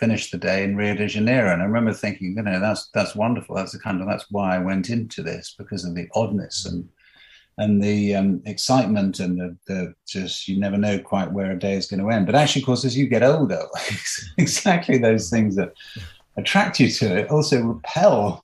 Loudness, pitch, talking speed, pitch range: -21 LUFS, 100 Hz, 220 wpm, 95-115 Hz